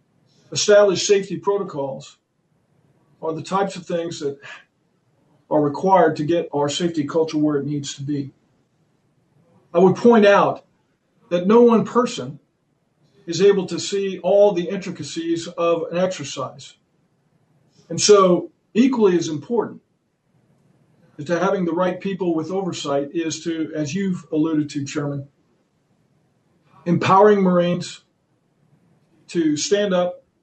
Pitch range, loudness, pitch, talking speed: 150-185 Hz, -19 LUFS, 165 Hz, 125 wpm